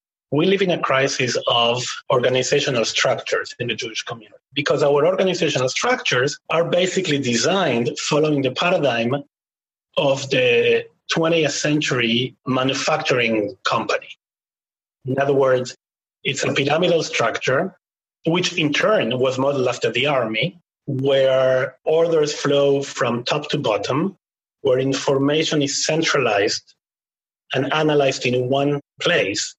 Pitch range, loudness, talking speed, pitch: 130-160 Hz, -19 LUFS, 120 wpm, 140 Hz